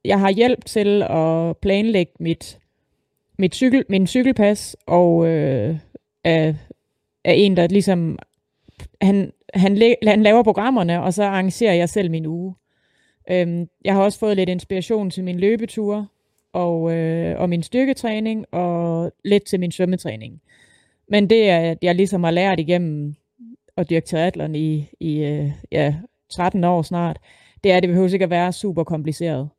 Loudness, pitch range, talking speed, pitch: -19 LUFS, 165-205 Hz, 155 wpm, 180 Hz